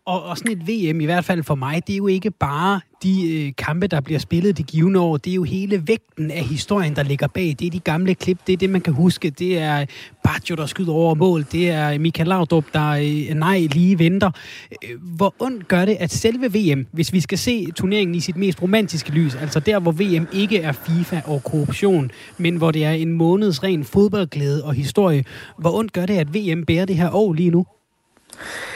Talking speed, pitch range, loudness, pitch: 225 wpm, 155-190 Hz, -19 LUFS, 170 Hz